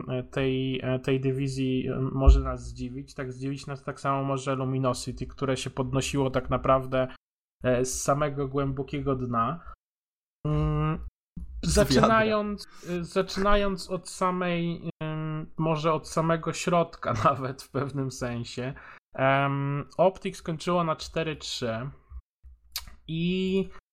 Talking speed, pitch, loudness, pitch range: 100 wpm, 140 Hz, -28 LUFS, 130-165 Hz